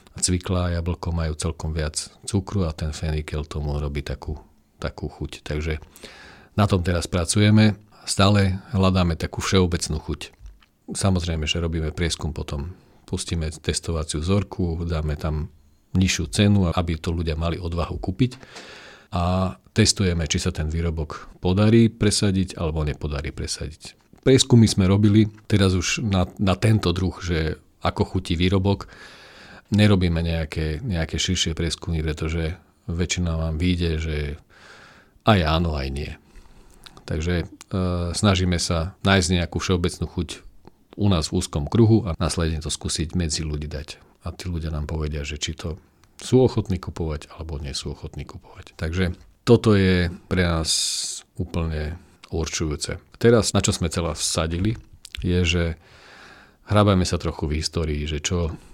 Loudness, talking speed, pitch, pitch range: -23 LUFS, 140 wpm, 85 Hz, 80-95 Hz